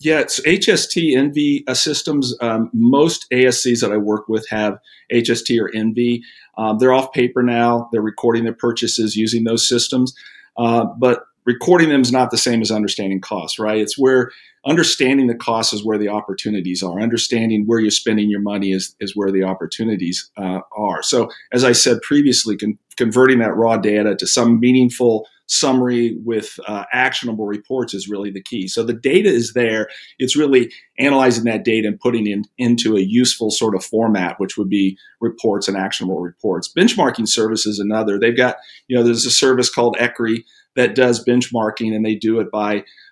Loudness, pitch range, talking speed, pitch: -17 LUFS, 105-125 Hz, 185 wpm, 115 Hz